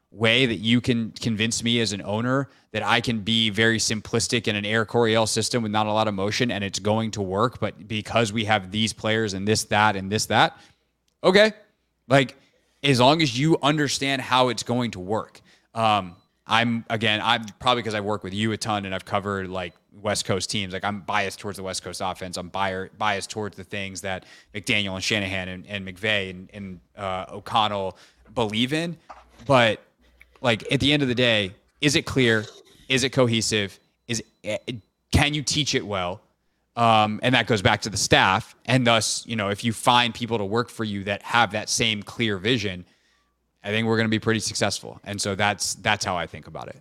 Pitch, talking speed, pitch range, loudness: 110 Hz, 210 wpm, 100-120 Hz, -23 LUFS